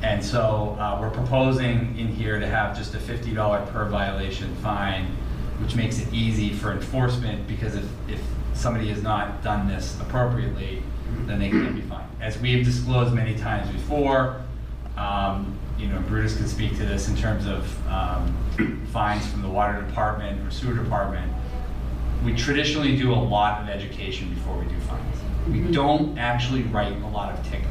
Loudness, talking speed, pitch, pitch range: -25 LUFS, 175 wpm, 105 Hz, 100-115 Hz